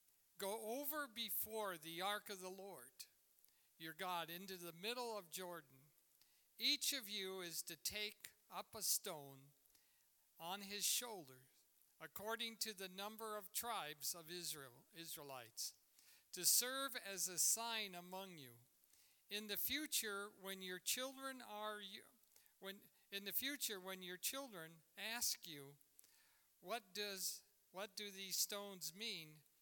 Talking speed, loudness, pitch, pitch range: 135 wpm, -45 LUFS, 195 Hz, 170-215 Hz